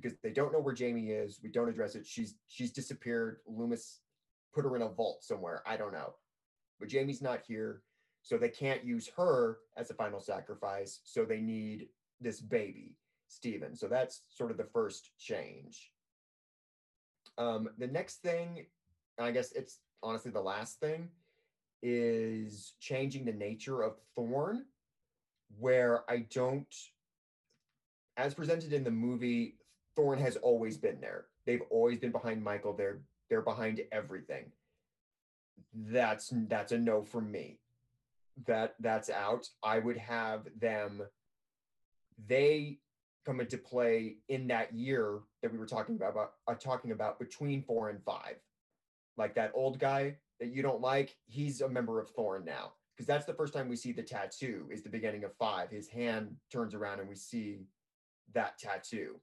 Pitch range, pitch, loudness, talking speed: 110-140 Hz, 120 Hz, -37 LUFS, 160 wpm